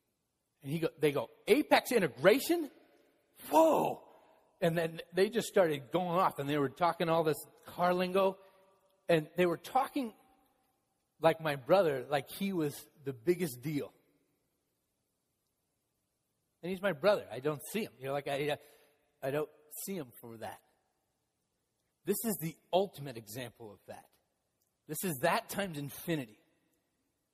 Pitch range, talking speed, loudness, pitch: 145-195 Hz, 145 wpm, -33 LUFS, 170 Hz